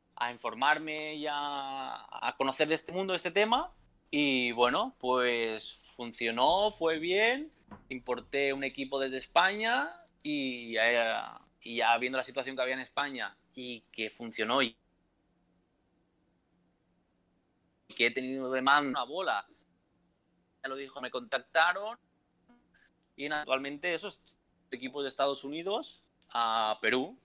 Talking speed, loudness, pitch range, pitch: 130 wpm, -31 LUFS, 125-155 Hz, 135 Hz